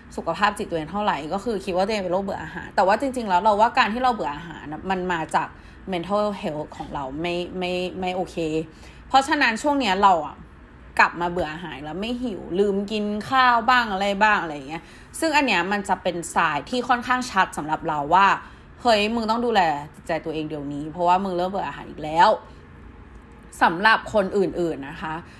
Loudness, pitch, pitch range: -22 LUFS, 190 Hz, 165-220 Hz